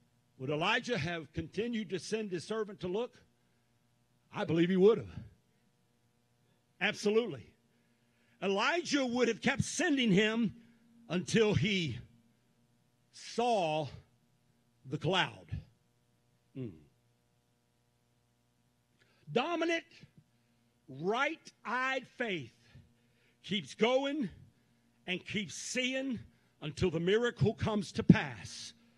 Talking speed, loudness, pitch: 85 wpm, -33 LUFS, 155 Hz